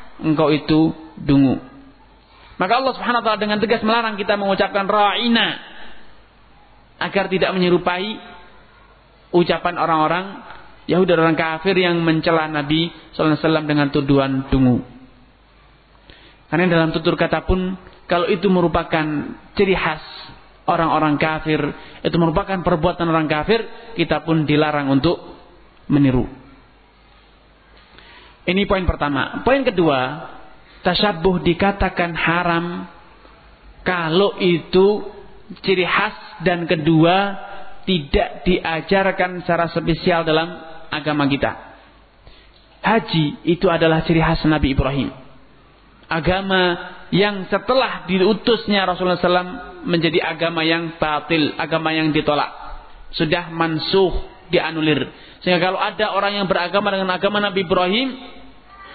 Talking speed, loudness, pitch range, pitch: 110 wpm, -18 LUFS, 155-195 Hz, 175 Hz